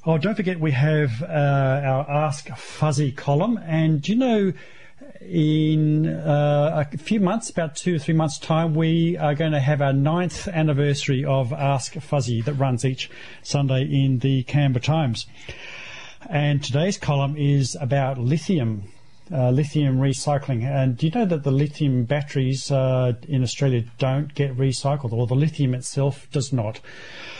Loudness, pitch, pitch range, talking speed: -22 LUFS, 145 Hz, 135-155 Hz, 160 wpm